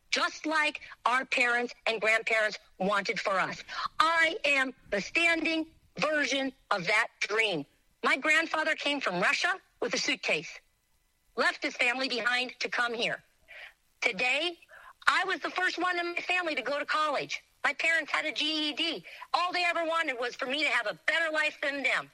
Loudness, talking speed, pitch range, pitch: -28 LUFS, 175 wpm, 245-330 Hz, 300 Hz